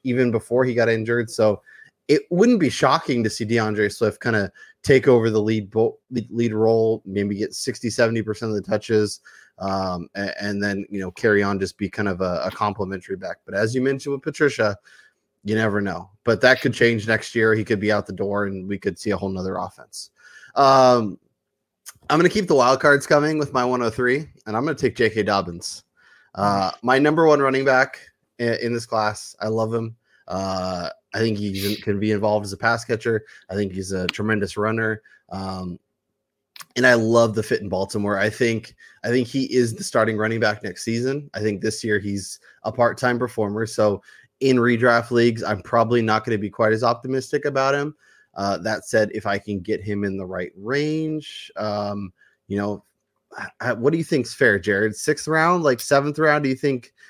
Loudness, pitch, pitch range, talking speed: -21 LUFS, 110 Hz, 100-125 Hz, 210 wpm